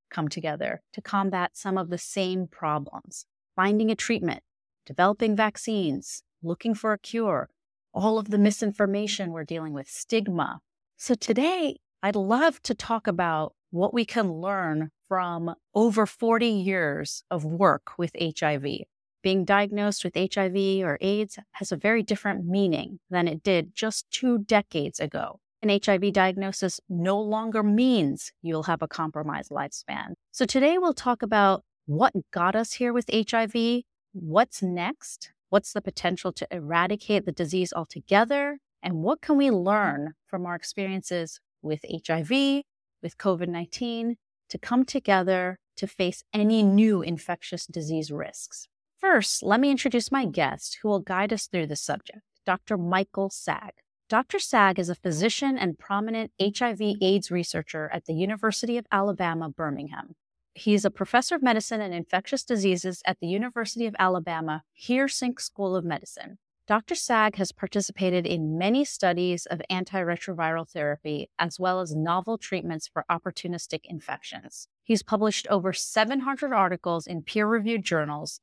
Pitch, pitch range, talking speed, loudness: 195 Hz, 175-220 Hz, 145 wpm, -26 LUFS